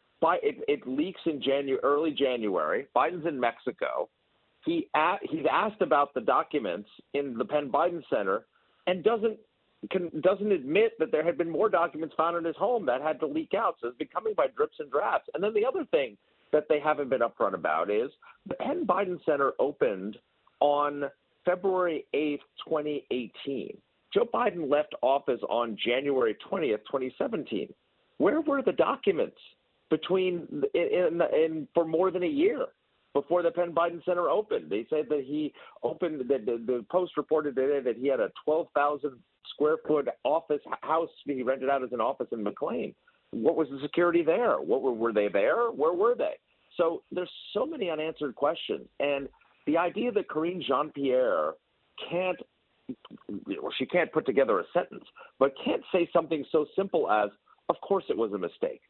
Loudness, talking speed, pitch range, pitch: -29 LUFS, 180 wpm, 145-220 Hz, 165 Hz